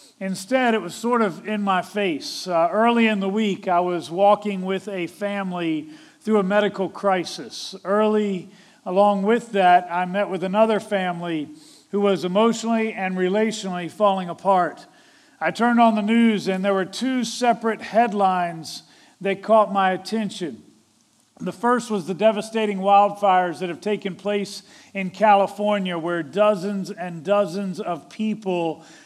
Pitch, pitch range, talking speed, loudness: 200 Hz, 185-215 Hz, 150 wpm, -22 LUFS